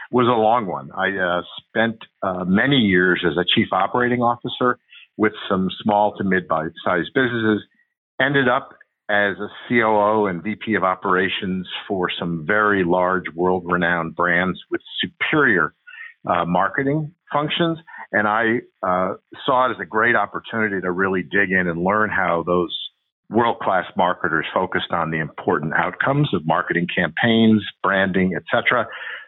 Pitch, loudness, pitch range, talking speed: 105 Hz, -20 LUFS, 90-120 Hz, 145 wpm